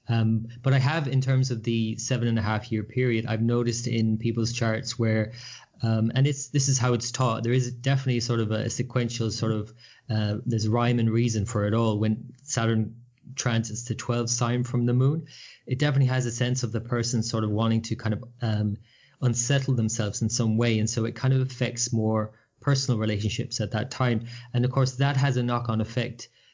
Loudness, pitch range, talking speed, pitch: -26 LUFS, 110-125 Hz, 215 wpm, 120 Hz